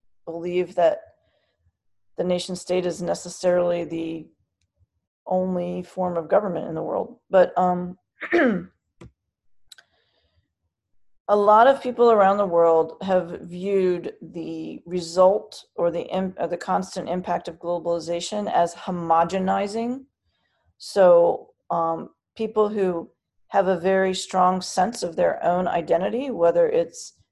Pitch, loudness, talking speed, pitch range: 180 Hz, -22 LUFS, 115 wpm, 170-195 Hz